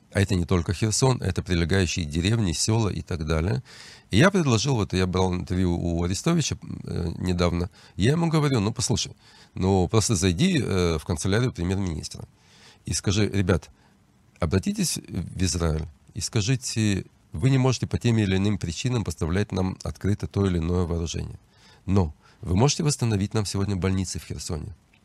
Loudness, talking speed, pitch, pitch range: -25 LUFS, 155 wpm, 100 Hz, 90-115 Hz